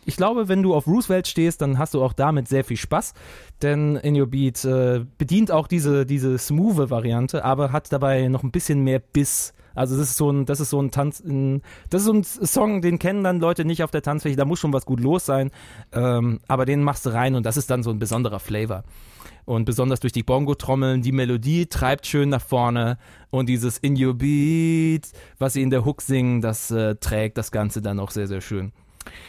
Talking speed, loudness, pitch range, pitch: 225 wpm, -22 LUFS, 120-150 Hz, 135 Hz